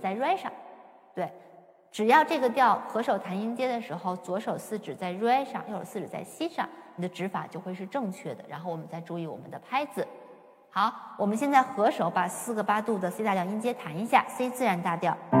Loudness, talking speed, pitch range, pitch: -29 LUFS, 310 characters per minute, 180-250 Hz, 205 Hz